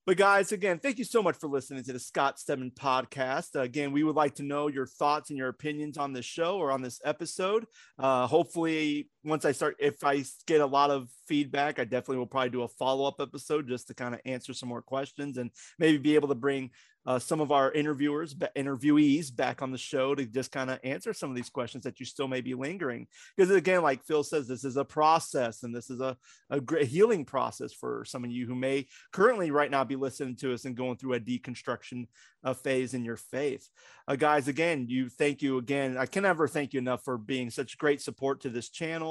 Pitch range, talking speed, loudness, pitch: 130-150 Hz, 235 wpm, -30 LUFS, 140 Hz